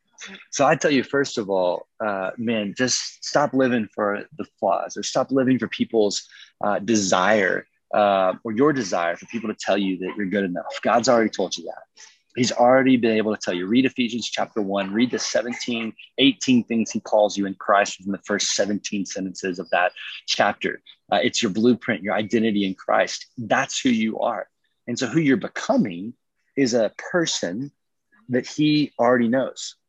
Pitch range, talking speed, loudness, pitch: 100-130 Hz, 185 wpm, -22 LUFS, 115 Hz